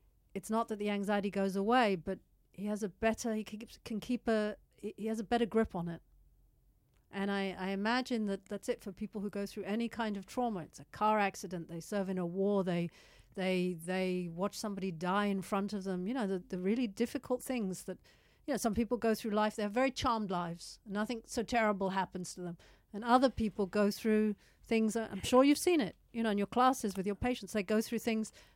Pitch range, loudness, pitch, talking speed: 195-230 Hz, -35 LUFS, 210 Hz, 225 wpm